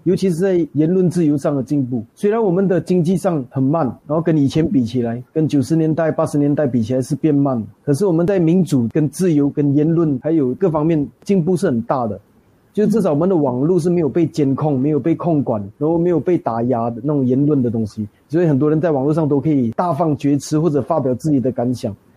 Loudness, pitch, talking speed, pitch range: -17 LUFS, 150 Hz, 345 characters per minute, 130-170 Hz